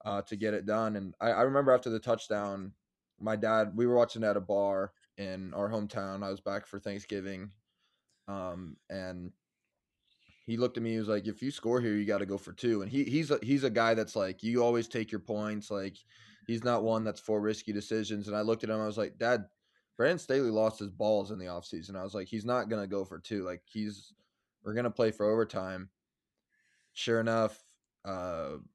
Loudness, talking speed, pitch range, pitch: -33 LUFS, 220 wpm, 100-115 Hz, 105 Hz